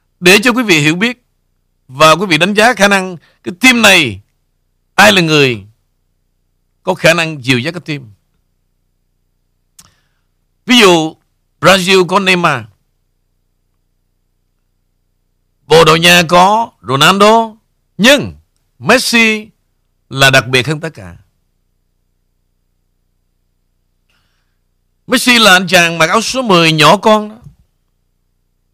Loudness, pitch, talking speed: -8 LUFS, 115 Hz, 115 wpm